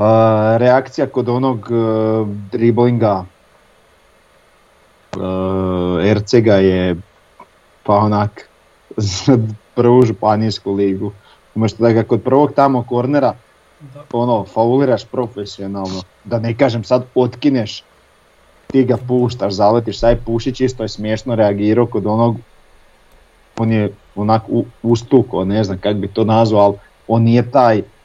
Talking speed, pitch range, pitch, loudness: 120 wpm, 100-120 Hz, 110 Hz, -15 LUFS